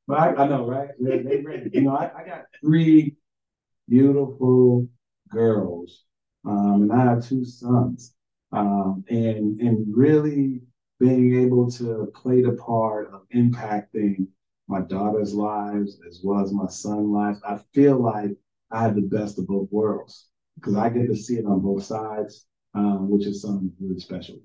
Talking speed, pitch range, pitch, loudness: 165 wpm, 100-125 Hz, 110 Hz, -22 LUFS